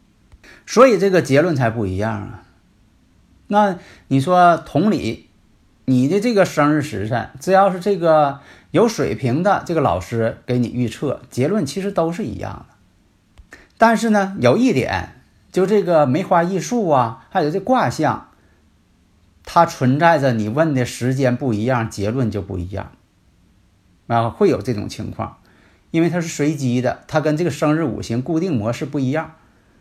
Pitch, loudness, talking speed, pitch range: 125 Hz, -18 LUFS, 235 characters per minute, 105-165 Hz